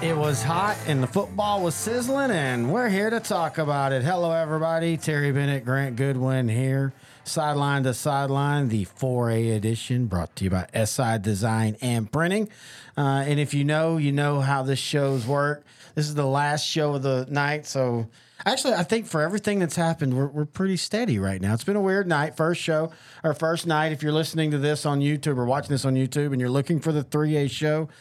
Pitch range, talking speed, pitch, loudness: 130-160 Hz, 210 wpm, 145 Hz, -24 LUFS